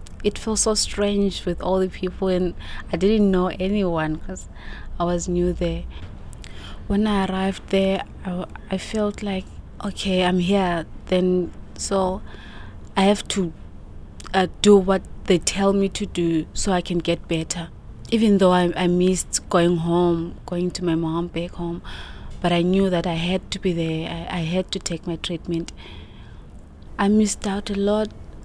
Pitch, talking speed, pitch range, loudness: 180 Hz, 170 wpm, 170-195 Hz, -22 LUFS